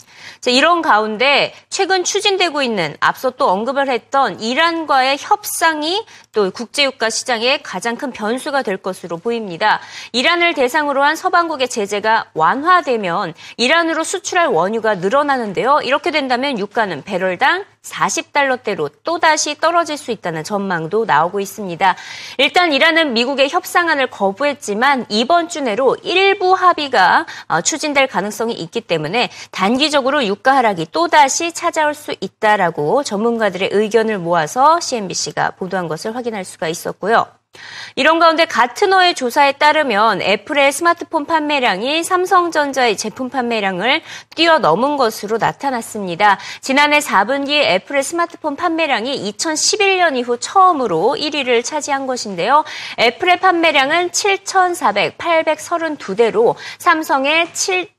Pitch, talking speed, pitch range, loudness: 280 Hz, 315 characters per minute, 225-330 Hz, -15 LUFS